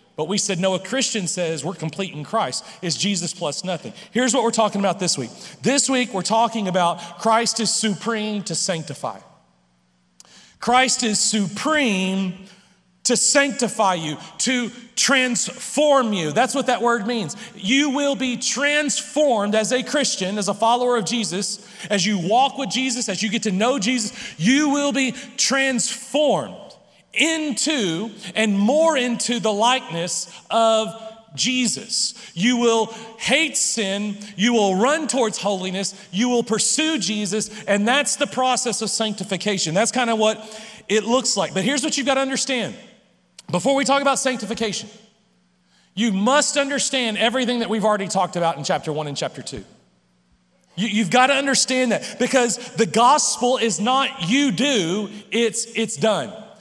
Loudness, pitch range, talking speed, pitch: -20 LUFS, 195-250 Hz, 160 wpm, 220 Hz